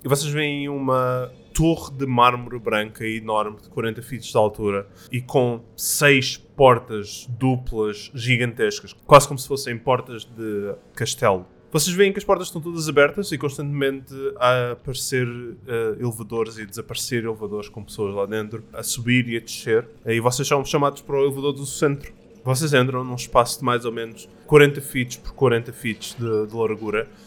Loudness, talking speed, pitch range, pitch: -22 LUFS, 170 wpm, 115-140 Hz, 125 Hz